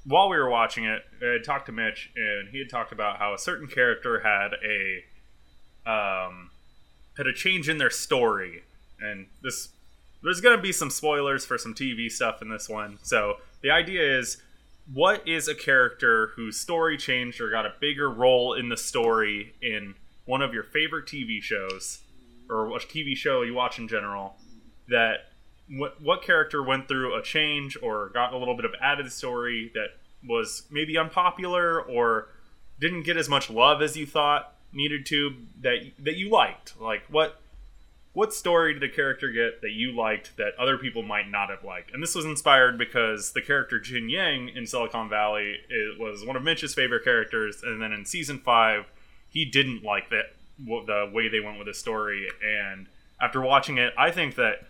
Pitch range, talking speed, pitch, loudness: 110-150 Hz, 190 wpm, 125 Hz, -25 LUFS